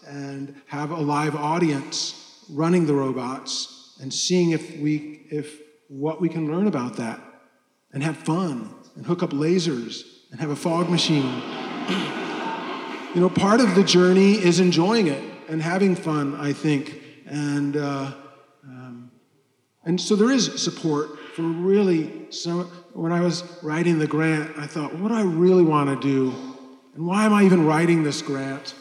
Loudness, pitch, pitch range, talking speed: -22 LUFS, 155 Hz, 140-175 Hz, 165 wpm